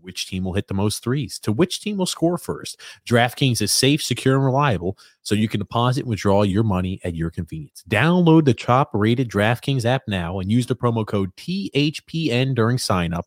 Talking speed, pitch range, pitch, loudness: 210 wpm, 100-135 Hz, 120 Hz, -21 LUFS